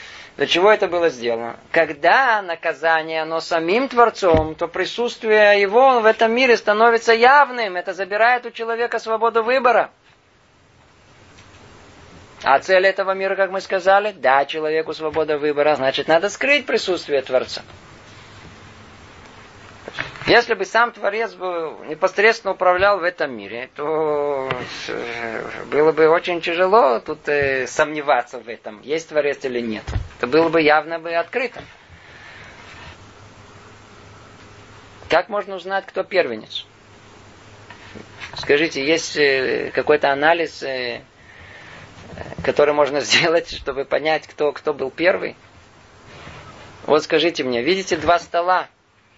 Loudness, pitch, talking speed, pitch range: -18 LUFS, 155 Hz, 115 wpm, 120-190 Hz